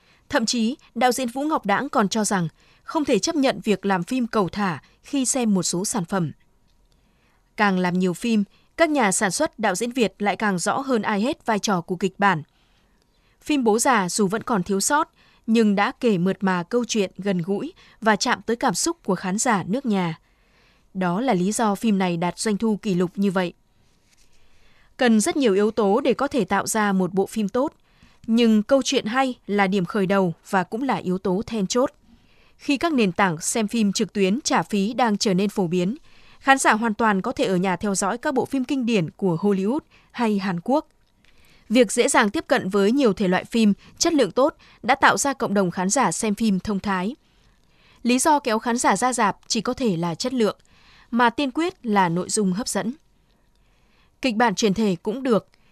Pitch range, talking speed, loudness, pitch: 195-250 Hz, 220 wpm, -22 LUFS, 215 Hz